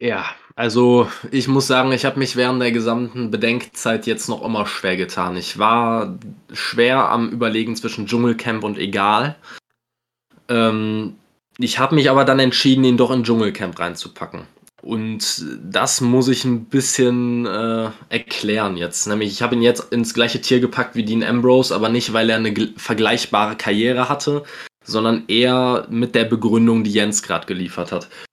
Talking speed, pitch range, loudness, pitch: 160 wpm, 110-125 Hz, -18 LUFS, 120 Hz